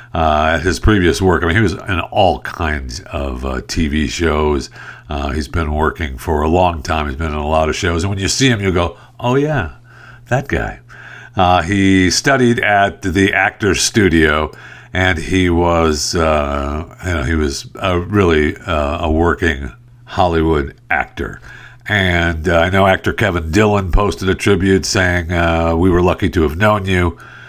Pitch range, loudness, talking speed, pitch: 80-100 Hz, -15 LUFS, 180 wpm, 90 Hz